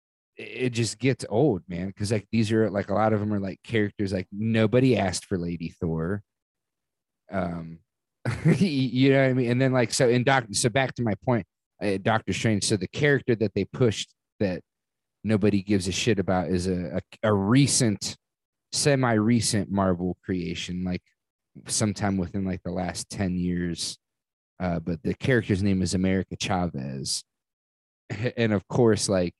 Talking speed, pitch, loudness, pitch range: 170 wpm, 100 Hz, -25 LUFS, 90-120 Hz